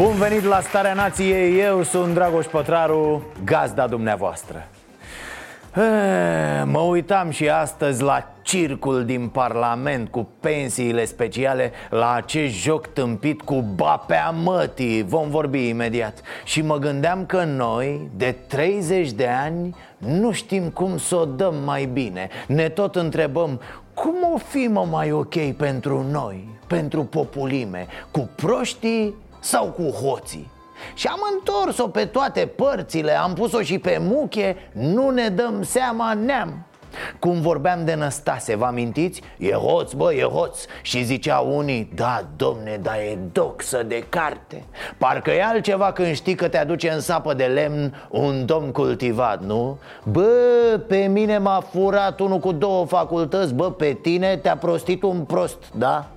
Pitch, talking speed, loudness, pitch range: 165 Hz, 145 wpm, -21 LUFS, 135-195 Hz